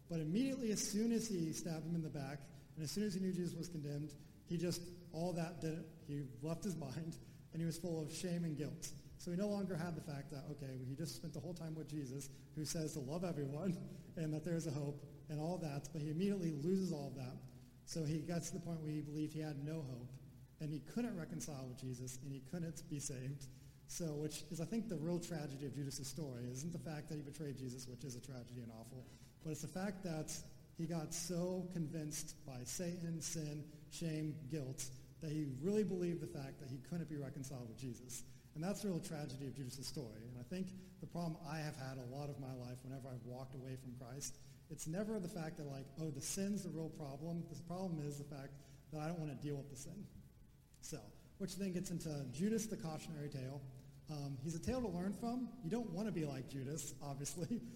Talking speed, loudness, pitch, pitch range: 235 wpm, -45 LUFS, 155 Hz, 140-170 Hz